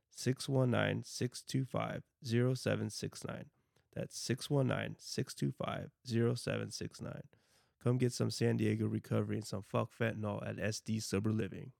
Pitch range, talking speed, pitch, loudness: 110-125 Hz, 85 wpm, 115 Hz, -37 LUFS